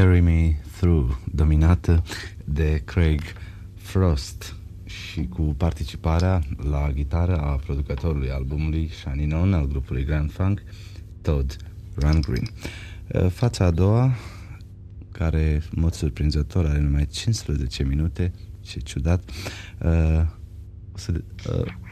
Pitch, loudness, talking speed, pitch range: 85 Hz, -24 LUFS, 110 wpm, 75-95 Hz